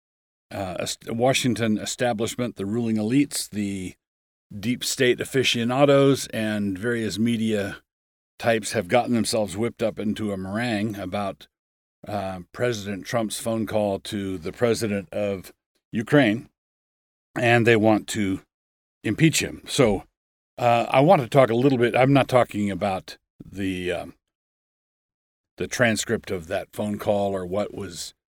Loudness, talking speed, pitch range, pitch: -23 LUFS, 135 wpm, 100-120 Hz, 110 Hz